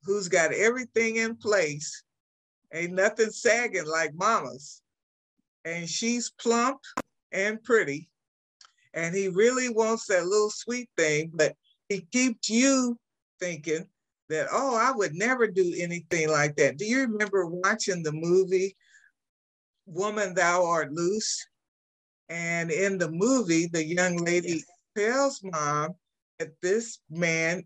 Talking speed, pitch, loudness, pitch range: 130 wpm, 185 Hz, -26 LUFS, 165-225 Hz